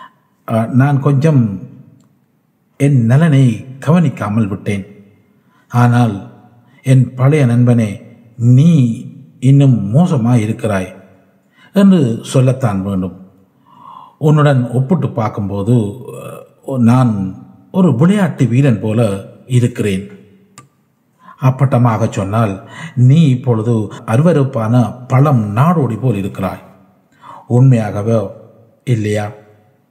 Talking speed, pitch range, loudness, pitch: 75 wpm, 105-135 Hz, -13 LUFS, 120 Hz